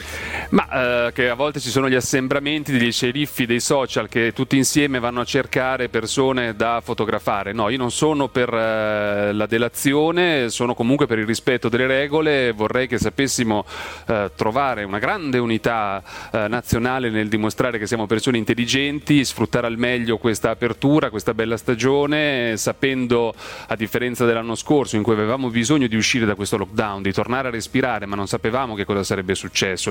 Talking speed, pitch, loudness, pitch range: 175 wpm, 120 Hz, -20 LUFS, 110-130 Hz